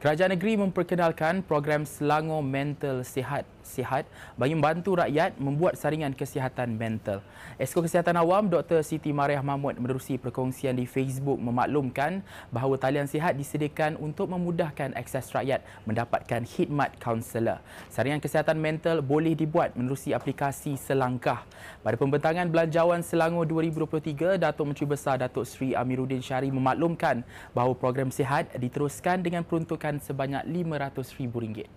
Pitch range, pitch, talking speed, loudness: 130-160 Hz, 145 Hz, 125 wpm, -28 LUFS